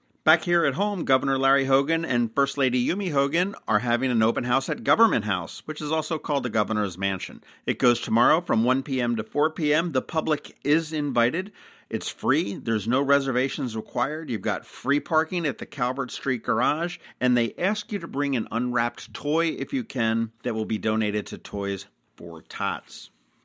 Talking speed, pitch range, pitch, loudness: 190 wpm, 115-155 Hz, 135 Hz, -25 LUFS